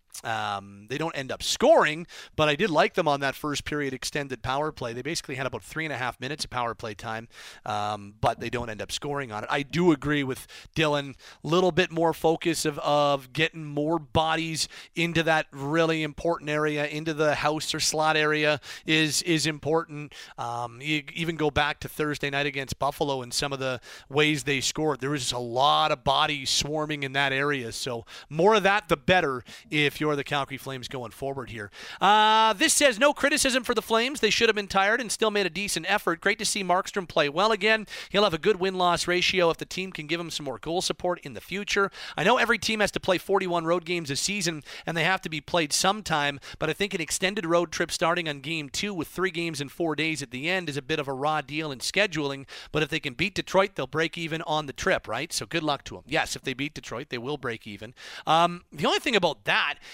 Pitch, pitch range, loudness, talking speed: 155 Hz, 140-175 Hz, -26 LUFS, 240 wpm